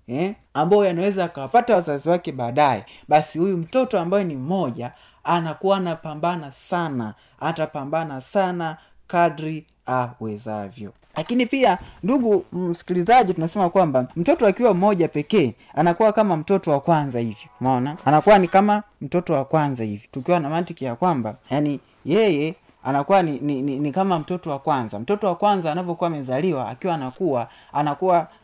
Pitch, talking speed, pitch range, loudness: 160 Hz, 140 wpm, 140-185 Hz, -21 LUFS